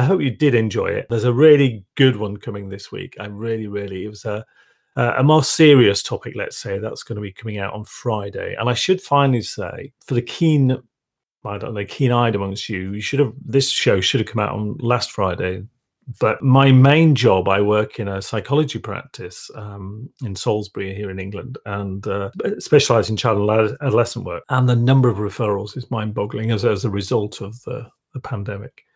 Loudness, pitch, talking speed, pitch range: -19 LUFS, 115 Hz, 210 wpm, 100-130 Hz